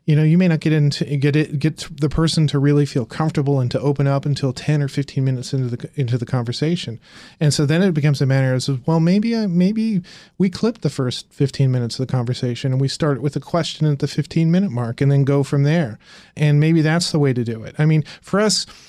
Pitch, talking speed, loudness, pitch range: 150 Hz, 250 wpm, -19 LUFS, 135-160 Hz